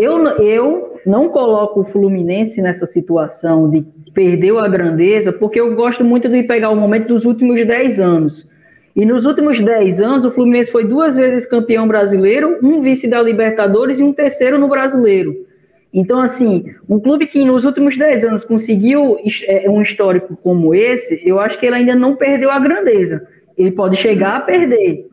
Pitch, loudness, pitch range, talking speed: 225 Hz, -13 LUFS, 195-255 Hz, 175 wpm